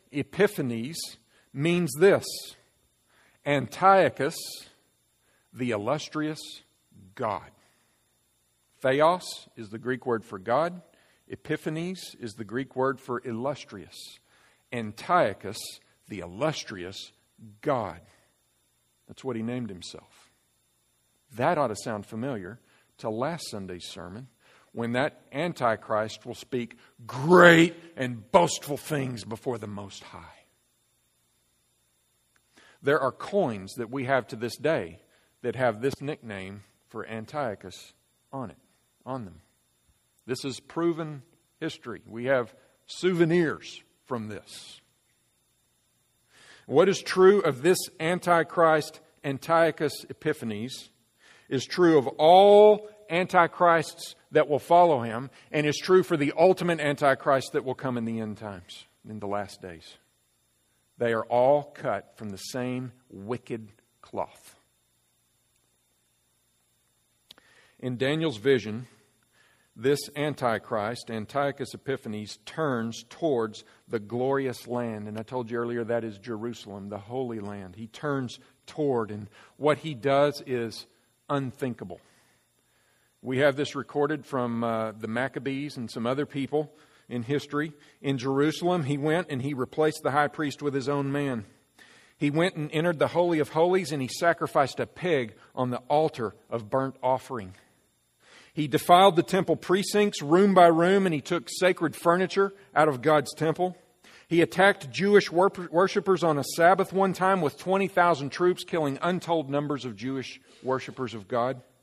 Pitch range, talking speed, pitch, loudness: 110-155 Hz, 130 wpm, 130 Hz, -26 LUFS